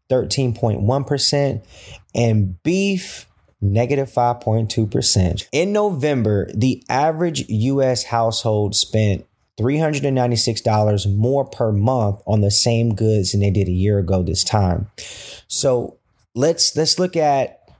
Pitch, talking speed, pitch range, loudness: 115 Hz, 110 wpm, 100-135 Hz, -18 LUFS